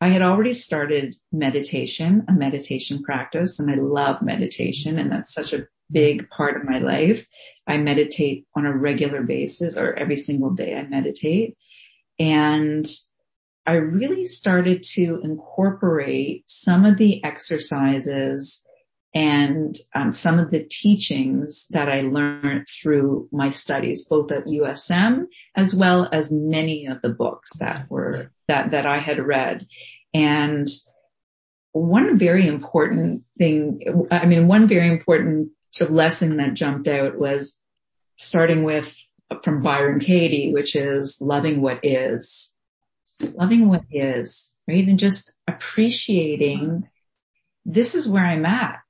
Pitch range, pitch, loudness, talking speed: 145-180 Hz, 155 Hz, -20 LUFS, 135 wpm